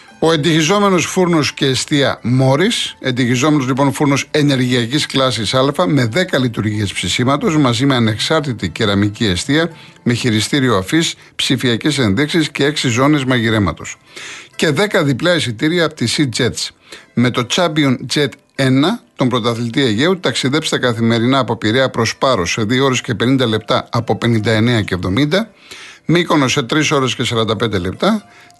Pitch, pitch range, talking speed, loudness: 135 Hz, 120-155 Hz, 145 wpm, -15 LUFS